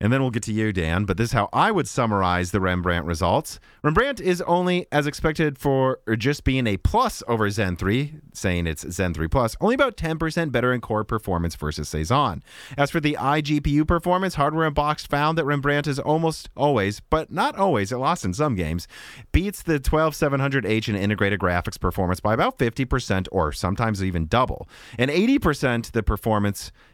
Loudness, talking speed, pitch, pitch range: -23 LUFS, 185 wpm, 125 Hz, 100-150 Hz